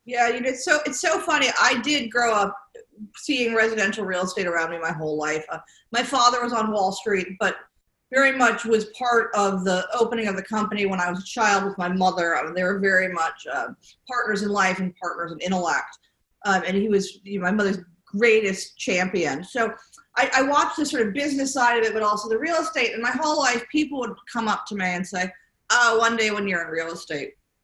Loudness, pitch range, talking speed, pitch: -23 LUFS, 185-245 Hz, 230 wpm, 215 Hz